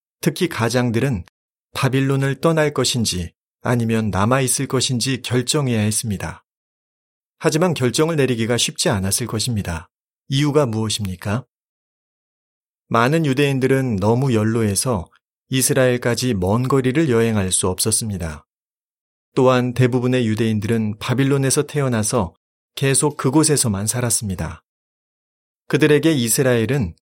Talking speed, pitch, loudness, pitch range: 295 characters per minute, 125 Hz, -19 LUFS, 110-135 Hz